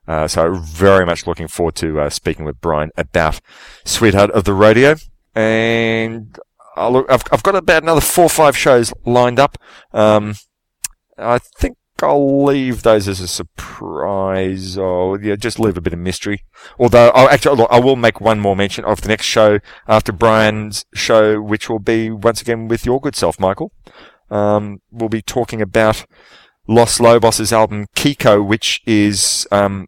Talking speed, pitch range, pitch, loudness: 175 wpm, 100-115 Hz, 110 Hz, -14 LUFS